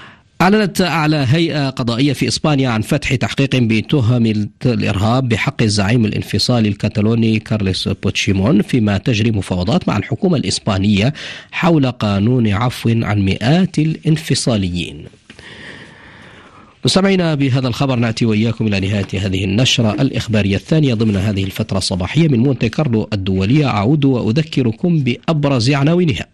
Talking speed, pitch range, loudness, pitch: 120 wpm, 105-140 Hz, -15 LUFS, 120 Hz